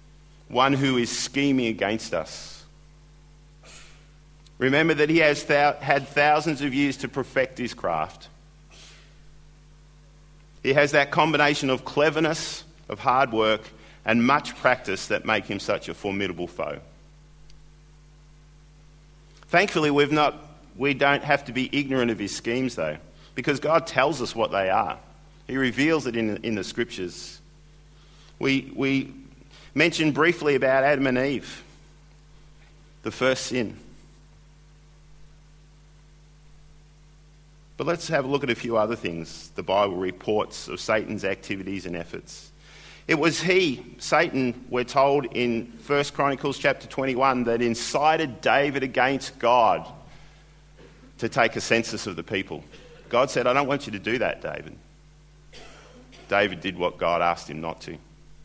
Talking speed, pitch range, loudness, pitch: 140 wpm, 125-150 Hz, -24 LUFS, 145 Hz